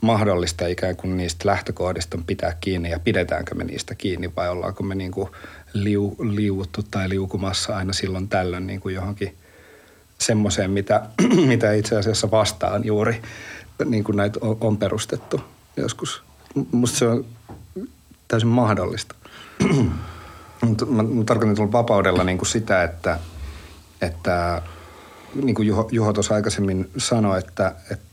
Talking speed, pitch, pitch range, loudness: 130 wpm, 100 Hz, 90-110 Hz, -22 LUFS